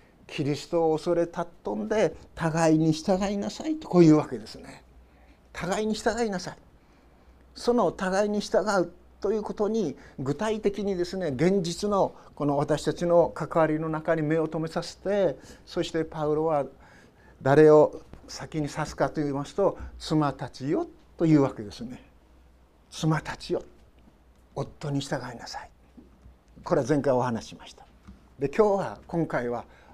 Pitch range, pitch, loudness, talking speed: 140-190 Hz, 160 Hz, -26 LUFS, 295 characters per minute